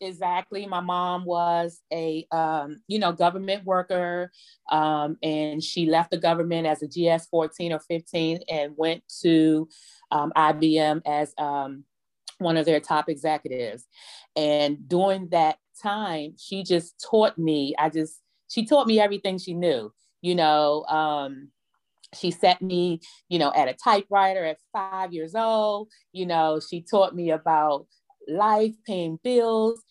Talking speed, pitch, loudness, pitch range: 150 wpm, 170 Hz, -24 LUFS, 155-190 Hz